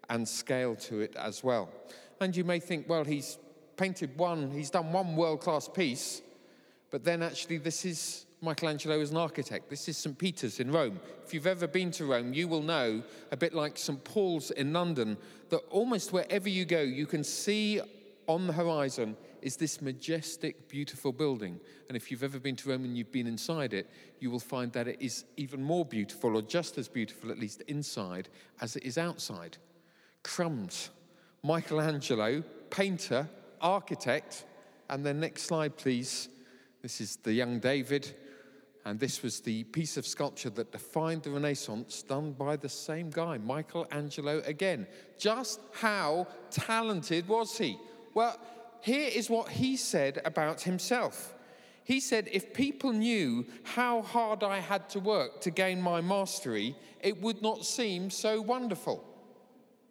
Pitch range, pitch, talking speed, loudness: 135-190 Hz, 160 Hz, 165 wpm, -33 LUFS